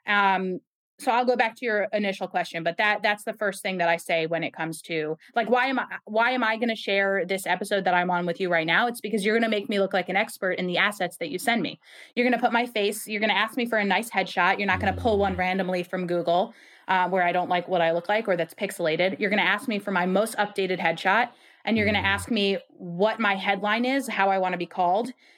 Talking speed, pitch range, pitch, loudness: 285 wpm, 180-220 Hz, 200 Hz, -25 LUFS